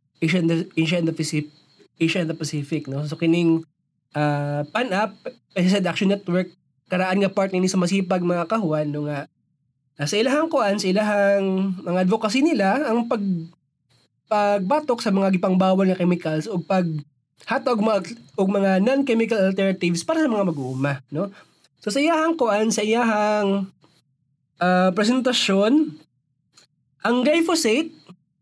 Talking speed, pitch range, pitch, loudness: 150 wpm, 155-210 Hz, 185 Hz, -21 LUFS